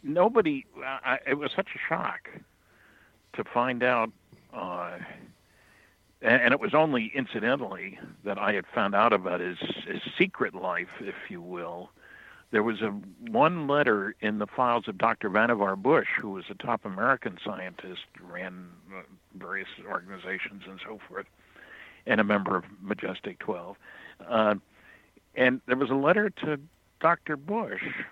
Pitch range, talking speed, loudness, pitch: 105-145 Hz, 145 wpm, -28 LUFS, 120 Hz